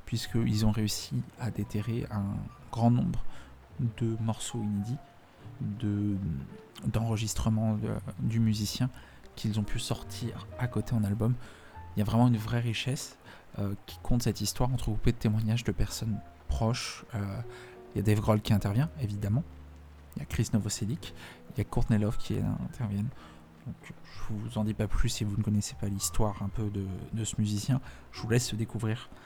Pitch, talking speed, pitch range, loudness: 110 Hz, 175 wpm, 100-115 Hz, -32 LUFS